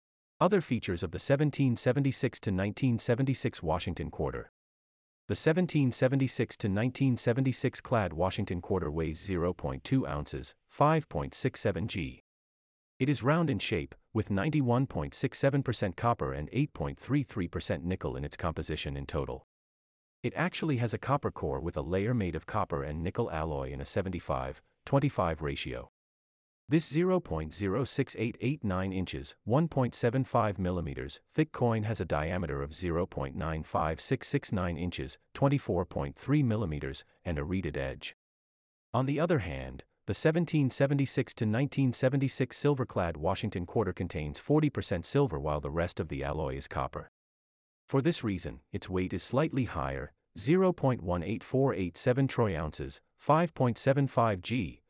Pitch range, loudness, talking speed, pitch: 80-130 Hz, -31 LUFS, 115 wpm, 100 Hz